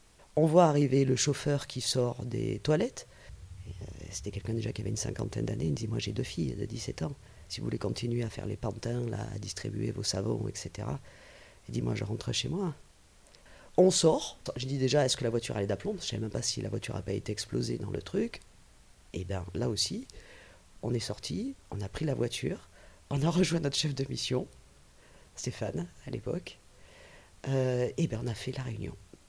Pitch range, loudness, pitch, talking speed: 100-135 Hz, -32 LUFS, 115 Hz, 215 wpm